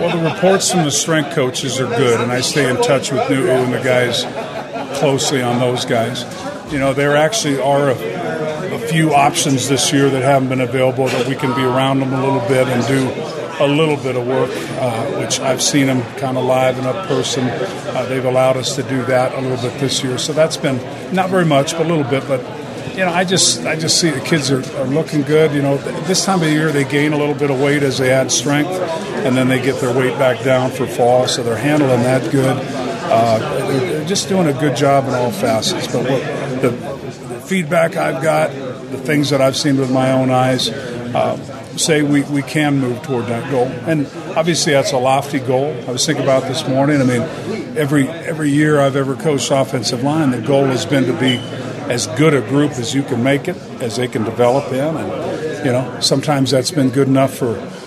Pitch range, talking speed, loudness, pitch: 130-150 Hz, 225 wpm, -16 LUFS, 135 Hz